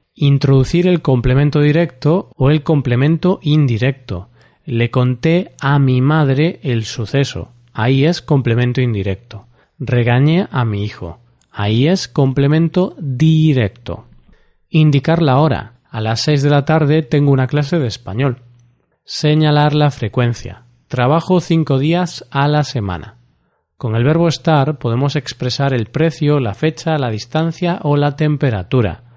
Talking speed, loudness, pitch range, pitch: 135 wpm, -15 LUFS, 120-155 Hz, 140 Hz